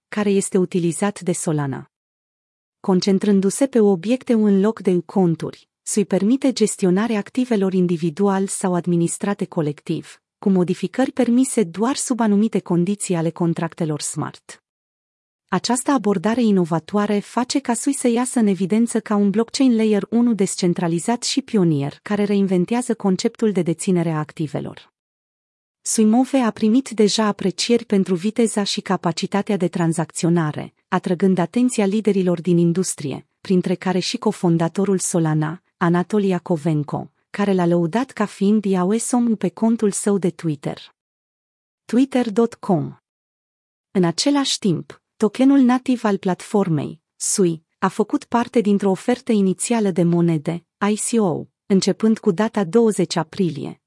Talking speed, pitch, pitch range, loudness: 125 wpm, 200 Hz, 175-225 Hz, -20 LUFS